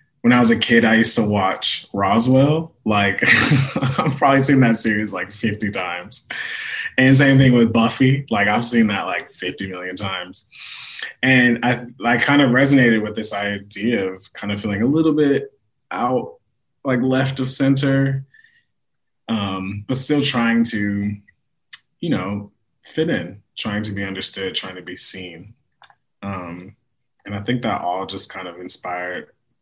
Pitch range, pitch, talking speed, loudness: 100-130 Hz, 115 Hz, 160 wpm, -18 LUFS